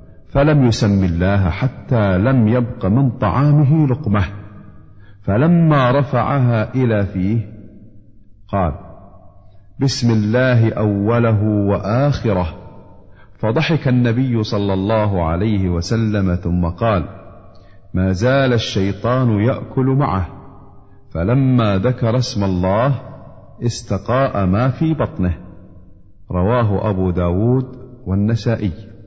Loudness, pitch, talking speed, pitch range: -17 LUFS, 105 Hz, 90 wpm, 95-125 Hz